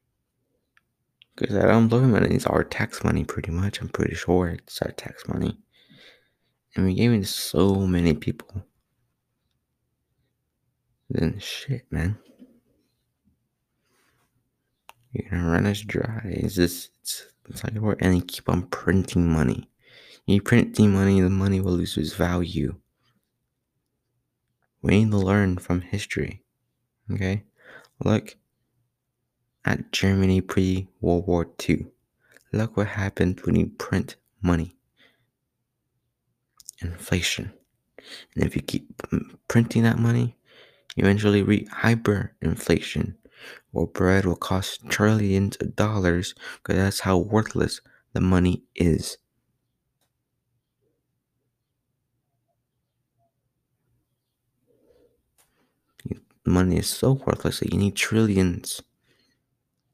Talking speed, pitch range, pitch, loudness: 110 wpm, 90-120 Hz, 105 Hz, -24 LUFS